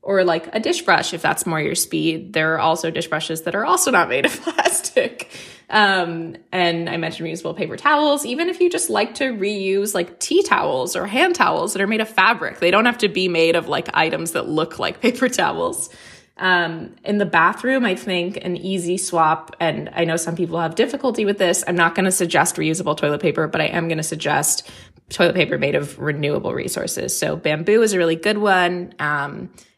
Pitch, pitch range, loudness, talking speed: 180 Hz, 165-215 Hz, -19 LUFS, 215 wpm